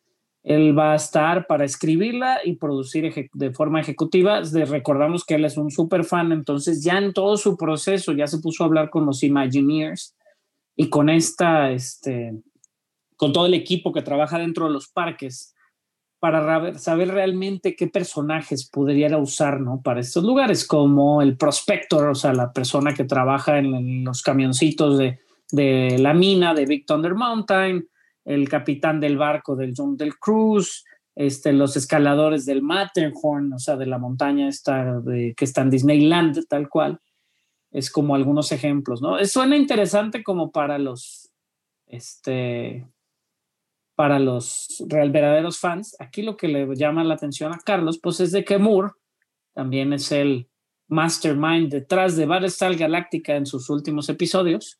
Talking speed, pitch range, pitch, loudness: 160 wpm, 140-175 Hz, 150 Hz, -21 LUFS